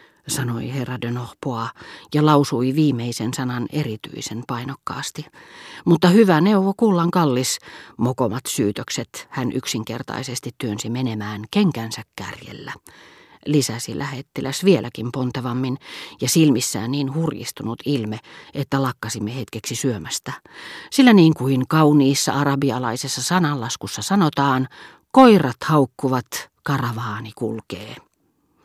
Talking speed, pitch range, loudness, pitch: 100 wpm, 120-150 Hz, -20 LUFS, 130 Hz